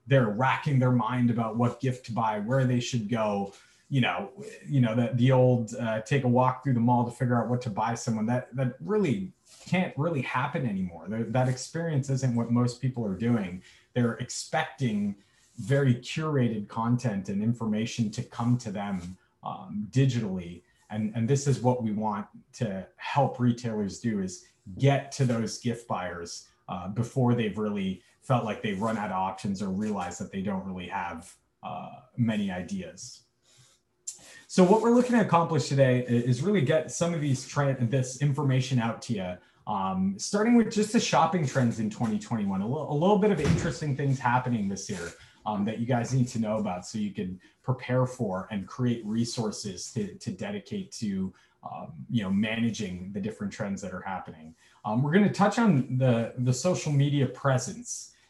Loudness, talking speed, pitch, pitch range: -28 LUFS, 185 wpm, 125 Hz, 110-140 Hz